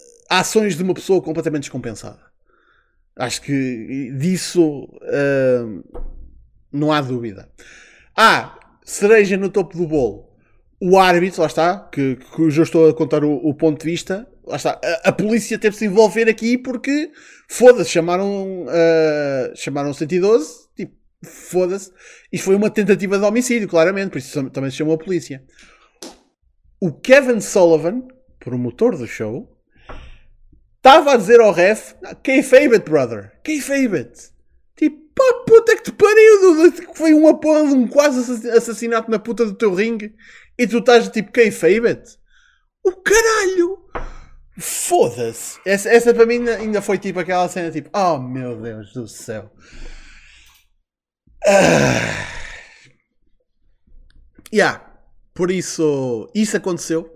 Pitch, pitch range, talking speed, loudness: 195 Hz, 160-245 Hz, 140 wpm, -16 LUFS